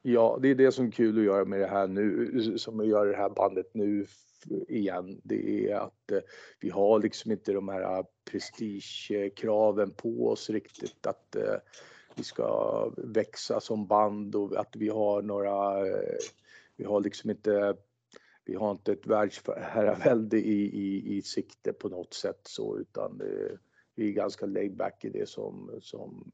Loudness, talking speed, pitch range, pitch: -30 LUFS, 165 wpm, 100-125 Hz, 105 Hz